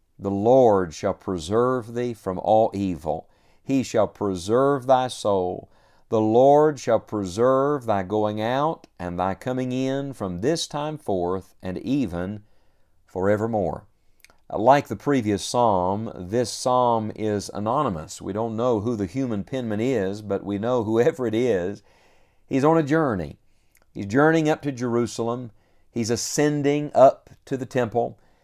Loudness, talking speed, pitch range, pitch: -23 LUFS, 145 wpm, 100-130 Hz, 110 Hz